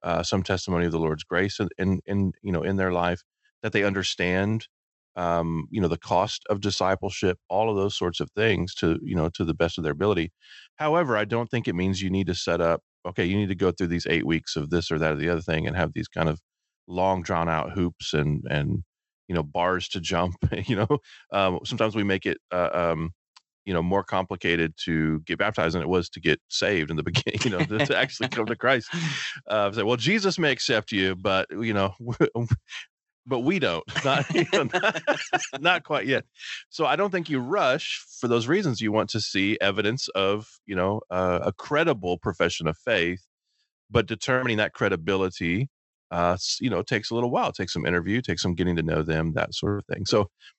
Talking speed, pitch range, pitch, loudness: 215 wpm, 85-110 Hz, 95 Hz, -25 LUFS